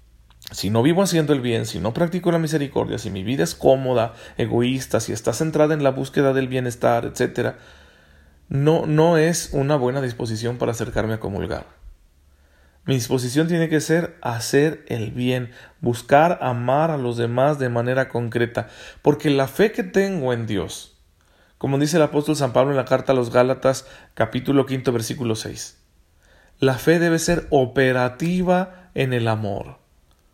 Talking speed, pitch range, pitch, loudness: 165 wpm, 110-150 Hz, 125 Hz, -21 LUFS